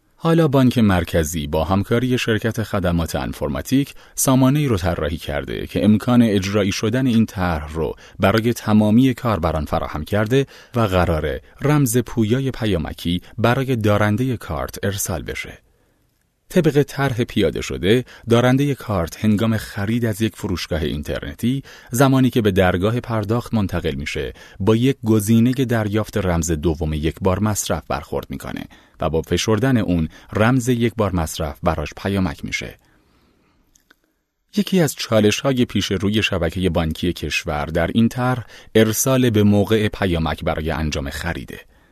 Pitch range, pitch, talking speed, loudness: 85-120 Hz, 105 Hz, 135 wpm, -19 LUFS